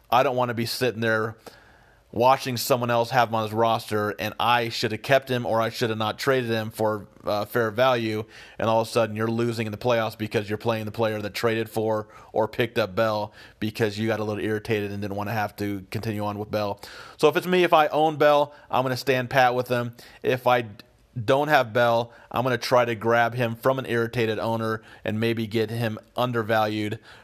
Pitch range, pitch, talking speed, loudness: 110-120 Hz, 115 Hz, 235 wpm, -24 LUFS